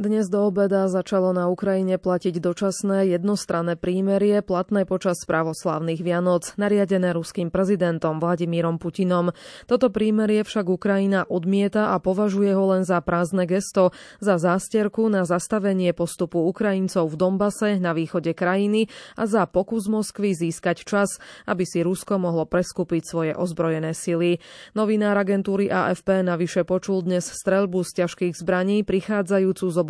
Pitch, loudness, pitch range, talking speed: 185 Hz, -22 LUFS, 175-200 Hz, 140 wpm